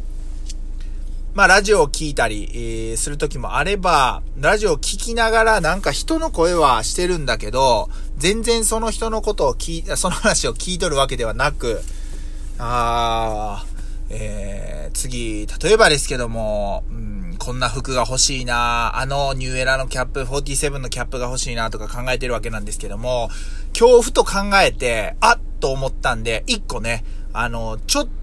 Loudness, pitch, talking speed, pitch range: -19 LUFS, 125 Hz, 315 characters per minute, 110-165 Hz